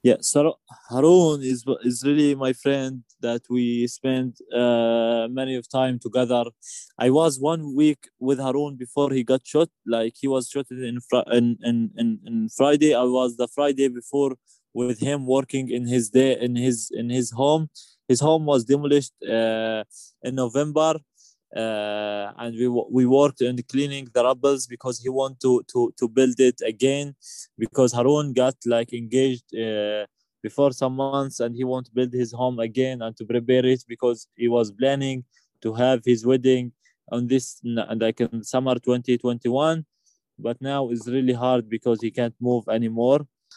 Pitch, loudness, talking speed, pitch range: 125 Hz, -23 LUFS, 170 wpm, 120-135 Hz